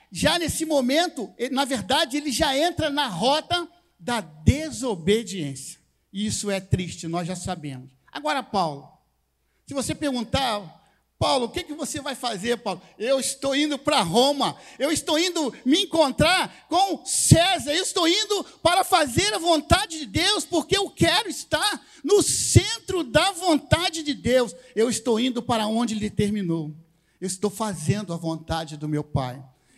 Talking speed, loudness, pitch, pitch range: 160 wpm, -23 LUFS, 265 Hz, 195-320 Hz